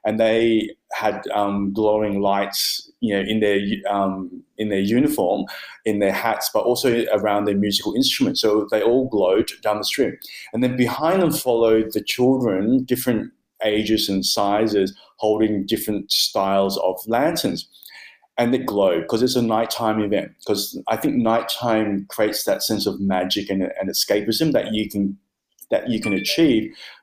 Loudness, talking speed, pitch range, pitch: -20 LUFS, 160 wpm, 100-115 Hz, 110 Hz